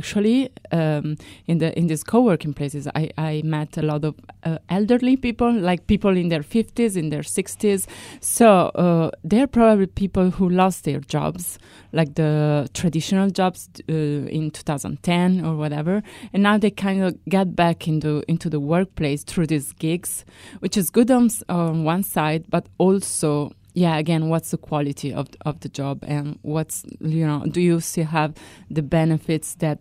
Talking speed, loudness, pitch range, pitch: 180 wpm, -21 LUFS, 150-190 Hz, 165 Hz